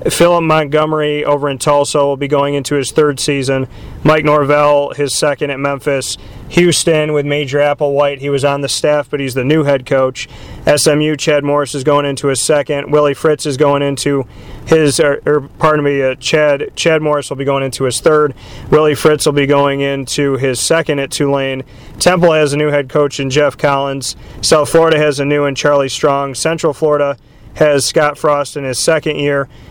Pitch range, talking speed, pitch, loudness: 140-150 Hz, 195 wpm, 145 Hz, -13 LUFS